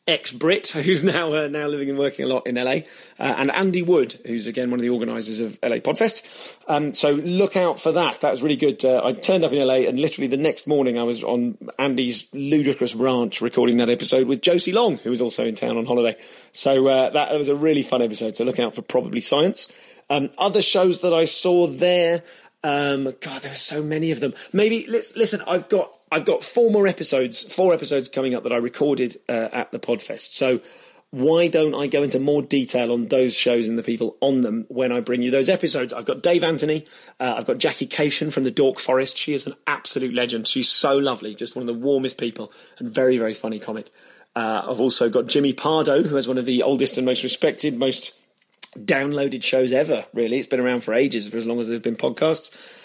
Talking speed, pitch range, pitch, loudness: 230 wpm, 125-155 Hz, 135 Hz, -21 LUFS